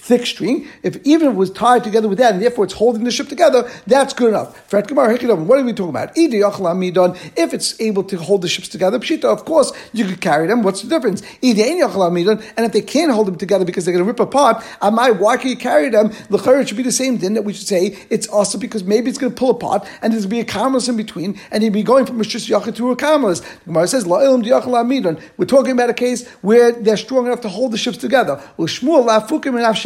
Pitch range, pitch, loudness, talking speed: 205-255 Hz, 230 Hz, -16 LUFS, 240 wpm